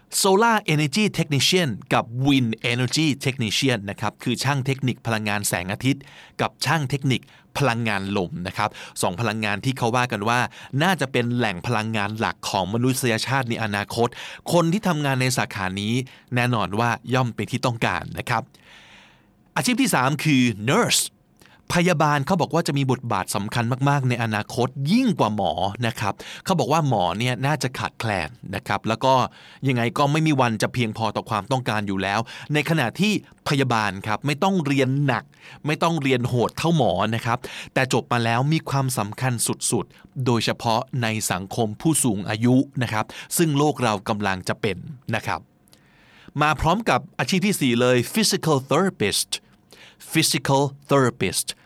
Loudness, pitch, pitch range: -22 LUFS, 125 Hz, 110-145 Hz